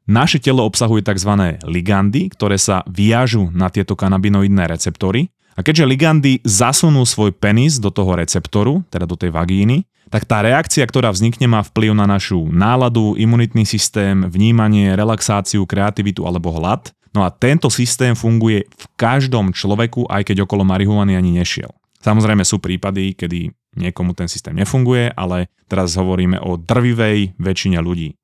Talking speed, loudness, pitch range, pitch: 150 wpm, -15 LUFS, 95-120 Hz, 105 Hz